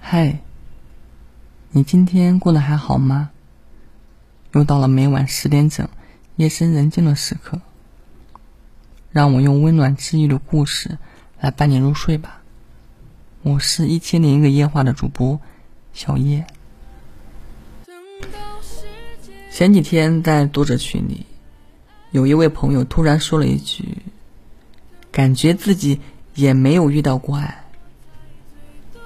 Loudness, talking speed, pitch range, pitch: -16 LUFS, 180 characters per minute, 135-160 Hz, 145 Hz